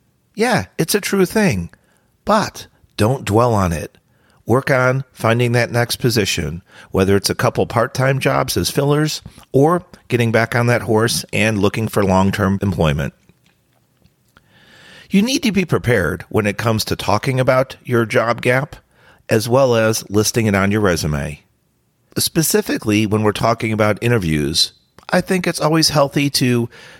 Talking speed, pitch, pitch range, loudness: 160 wpm, 120 Hz, 105-135 Hz, -17 LUFS